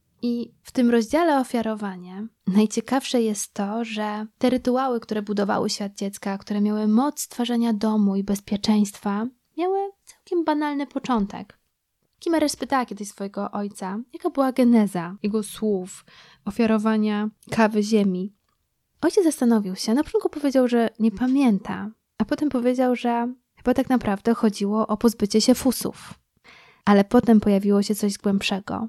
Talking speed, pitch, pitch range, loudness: 135 wpm, 220 Hz, 205-255 Hz, -23 LUFS